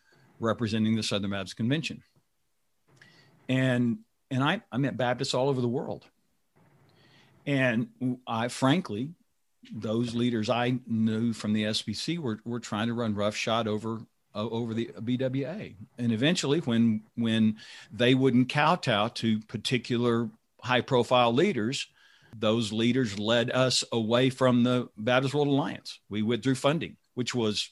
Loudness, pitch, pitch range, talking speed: -28 LUFS, 120 Hz, 110-130 Hz, 135 wpm